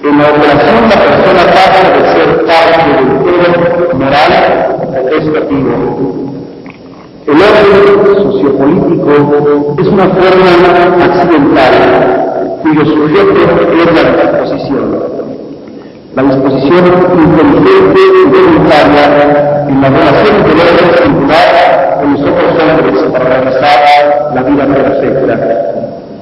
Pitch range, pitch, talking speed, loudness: 145-185 Hz, 155 Hz, 105 wpm, -6 LUFS